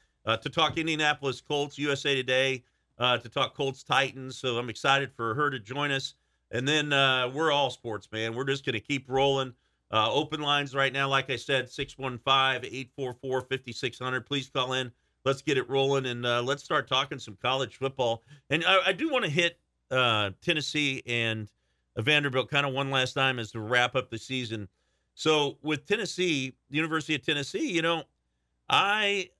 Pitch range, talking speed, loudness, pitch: 125-145 Hz, 185 wpm, -28 LUFS, 135 Hz